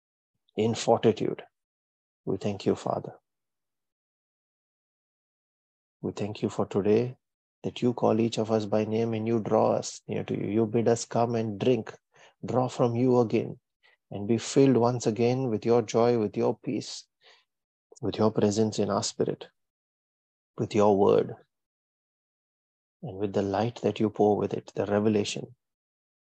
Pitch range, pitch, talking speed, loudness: 105-115 Hz, 110 Hz, 155 wpm, -27 LUFS